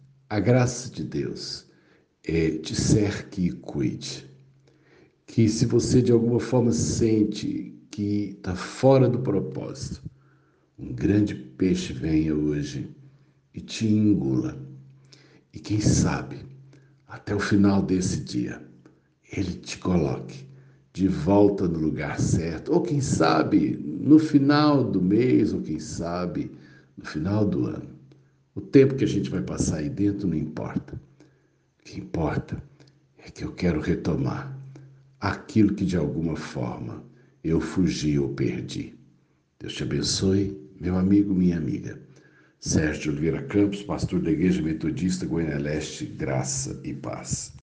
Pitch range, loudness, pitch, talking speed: 90-135 Hz, -25 LUFS, 105 Hz, 135 wpm